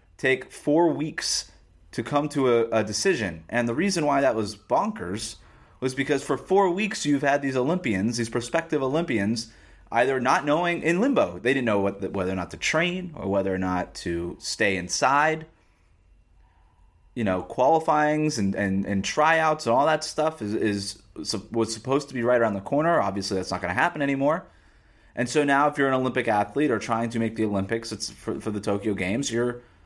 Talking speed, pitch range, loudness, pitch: 205 wpm, 100-145 Hz, -25 LUFS, 115 Hz